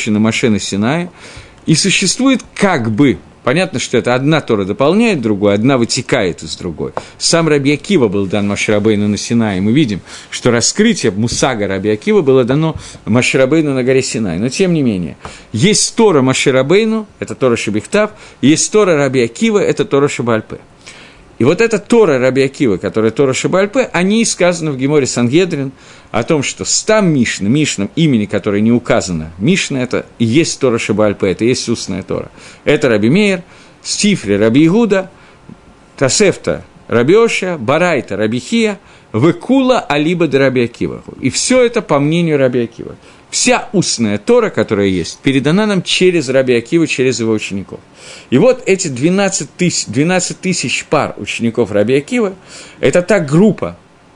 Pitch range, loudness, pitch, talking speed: 115-185 Hz, -13 LUFS, 140 Hz, 150 wpm